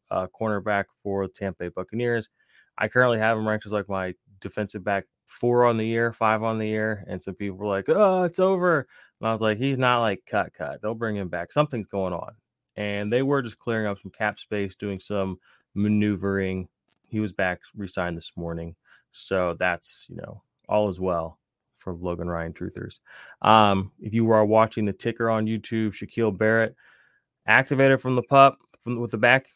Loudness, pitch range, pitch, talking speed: -24 LUFS, 95-115 Hz, 105 Hz, 195 wpm